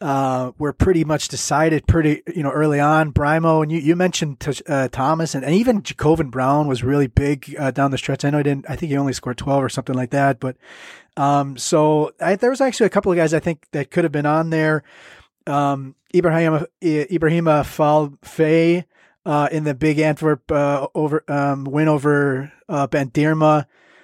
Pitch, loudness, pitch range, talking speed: 150 Hz, -19 LUFS, 140-160 Hz, 195 wpm